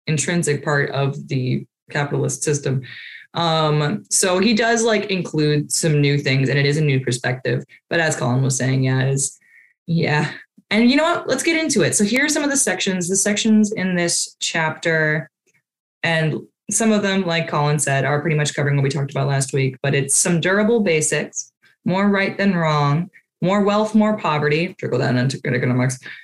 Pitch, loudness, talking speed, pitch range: 155 Hz, -19 LUFS, 195 wpm, 140-195 Hz